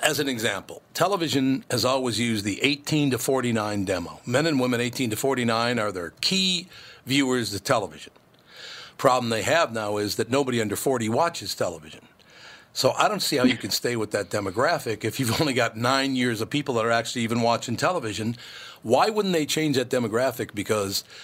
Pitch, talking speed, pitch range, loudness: 125 Hz, 190 wpm, 115-140 Hz, -24 LUFS